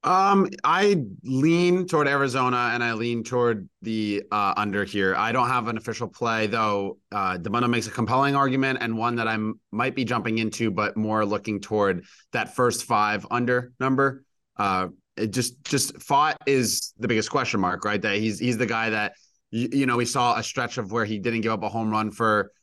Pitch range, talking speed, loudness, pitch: 110-130 Hz, 205 wpm, -24 LUFS, 120 Hz